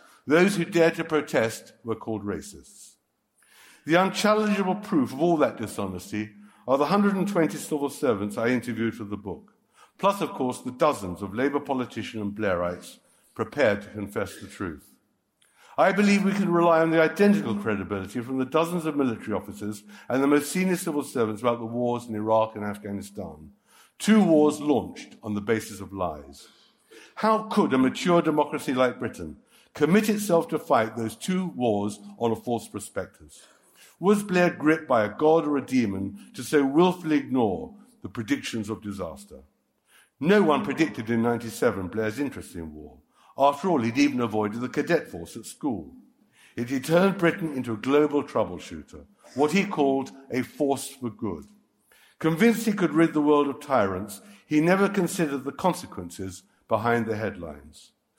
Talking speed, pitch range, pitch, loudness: 165 wpm, 110-165 Hz, 135 Hz, -25 LUFS